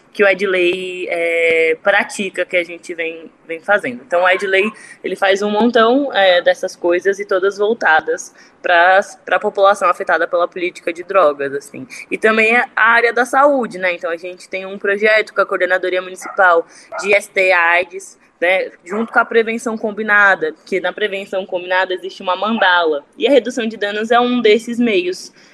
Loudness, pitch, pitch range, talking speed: -15 LUFS, 195 Hz, 180-220 Hz, 175 wpm